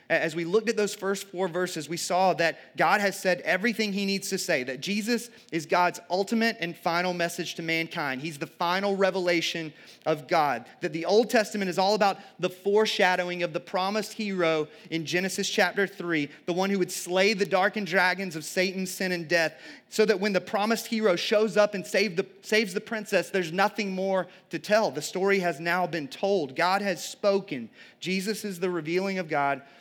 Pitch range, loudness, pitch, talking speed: 175-200 Hz, -27 LUFS, 185 Hz, 195 wpm